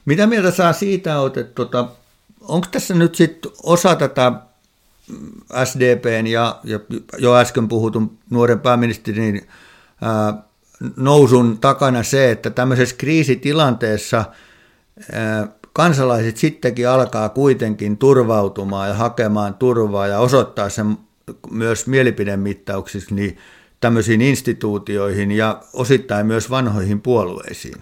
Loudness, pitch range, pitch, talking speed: -17 LUFS, 105-130 Hz, 120 Hz, 100 wpm